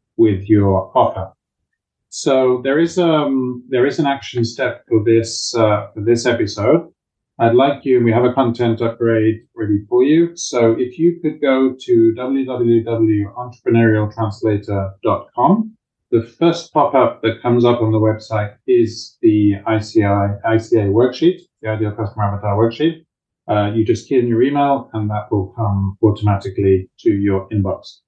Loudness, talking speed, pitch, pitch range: -16 LUFS, 155 wpm, 115 Hz, 105-130 Hz